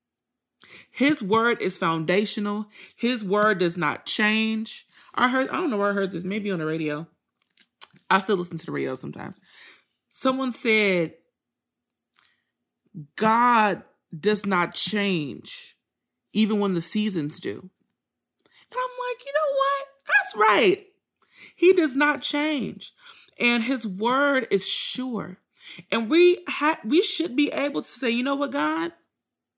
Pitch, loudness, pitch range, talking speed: 225 Hz, -23 LUFS, 195-285 Hz, 140 wpm